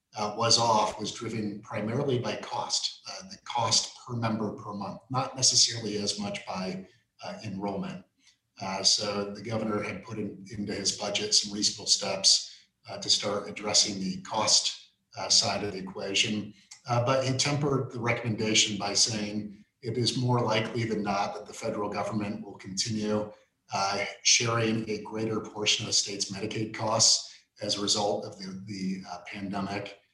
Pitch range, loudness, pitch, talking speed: 100-110 Hz, -27 LUFS, 105 Hz, 165 wpm